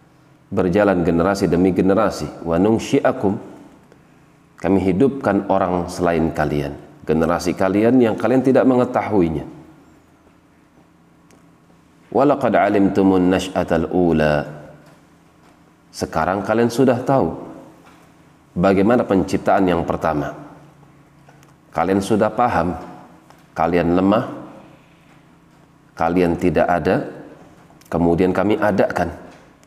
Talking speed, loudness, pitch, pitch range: 70 wpm, -18 LUFS, 95 Hz, 85-115 Hz